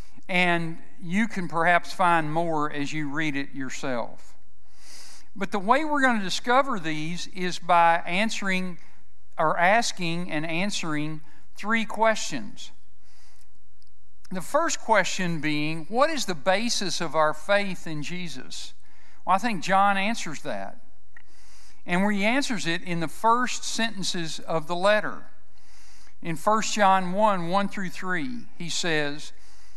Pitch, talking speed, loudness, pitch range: 175 Hz, 135 wpm, -25 LUFS, 150-205 Hz